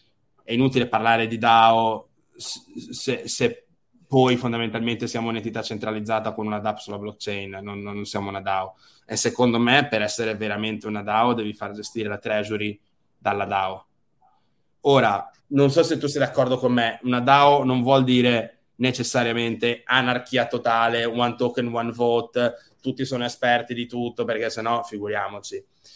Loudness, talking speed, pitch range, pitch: -22 LUFS, 155 wpm, 105-125 Hz, 115 Hz